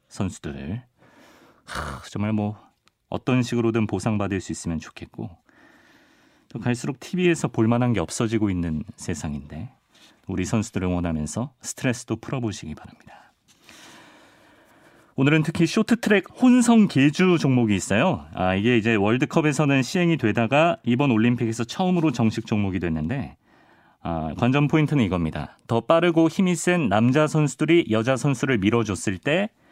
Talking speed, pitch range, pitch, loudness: 320 characters per minute, 105-160 Hz, 120 Hz, -22 LUFS